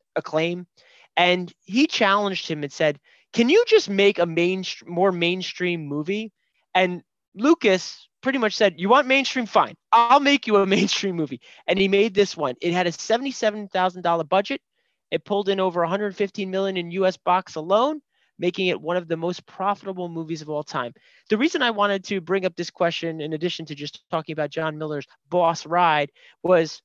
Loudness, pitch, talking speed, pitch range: -22 LUFS, 185 Hz, 190 wpm, 170-205 Hz